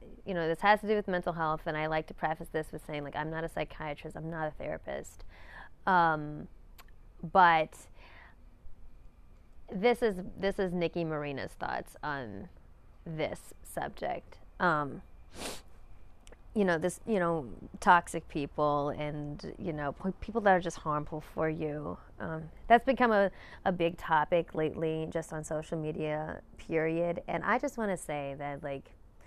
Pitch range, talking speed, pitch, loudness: 150-180 Hz, 160 wpm, 160 Hz, -32 LUFS